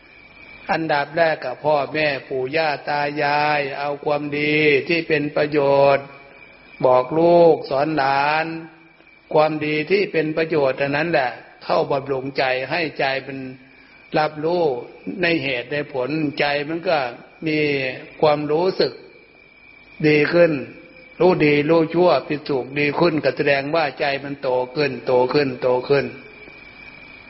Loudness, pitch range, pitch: -20 LUFS, 140-160 Hz, 150 Hz